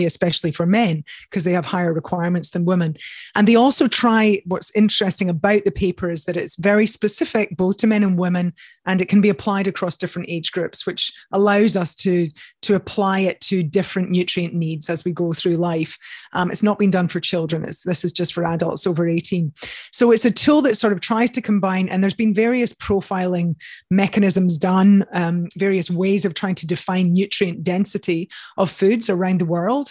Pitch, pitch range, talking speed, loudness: 185 Hz, 175-205 Hz, 200 wpm, -19 LUFS